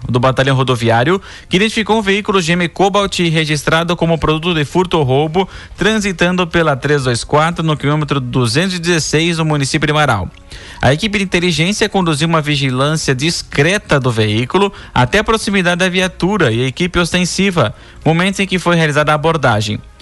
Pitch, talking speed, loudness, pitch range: 160 Hz, 155 wpm, -14 LUFS, 140-185 Hz